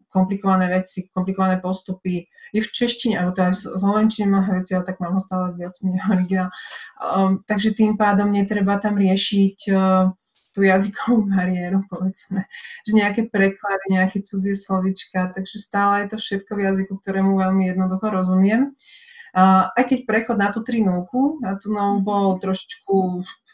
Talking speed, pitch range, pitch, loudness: 160 wpm, 185-210 Hz, 195 Hz, -20 LUFS